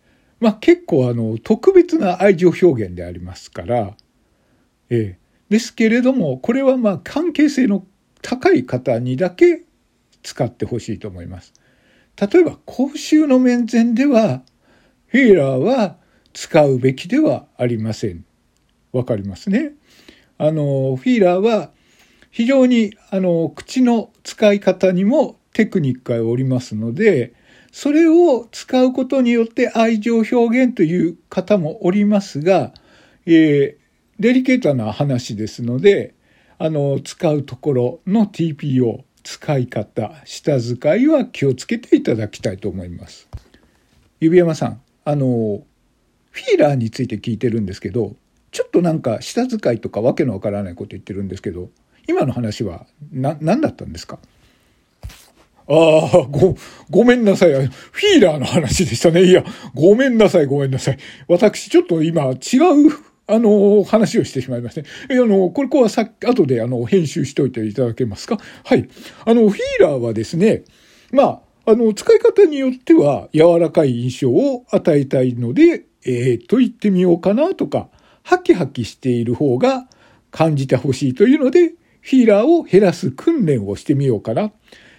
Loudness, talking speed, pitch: -16 LUFS, 310 characters per minute, 175 Hz